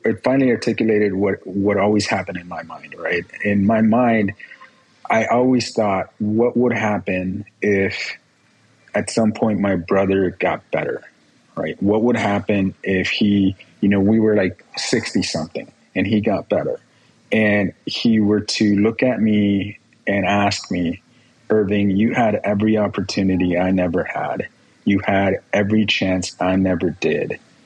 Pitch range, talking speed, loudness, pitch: 95-110 Hz, 150 wpm, -19 LUFS, 105 Hz